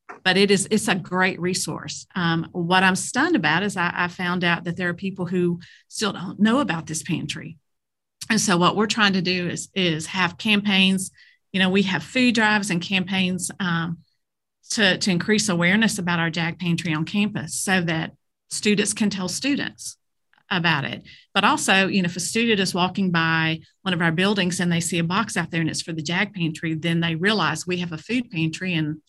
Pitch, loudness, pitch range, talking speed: 180 Hz, -22 LUFS, 170-200 Hz, 210 wpm